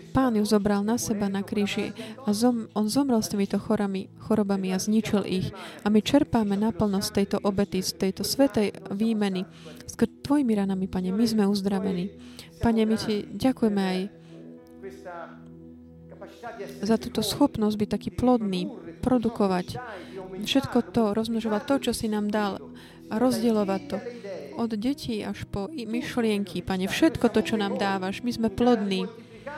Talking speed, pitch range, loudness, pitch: 150 wpm, 195-230 Hz, -26 LUFS, 210 Hz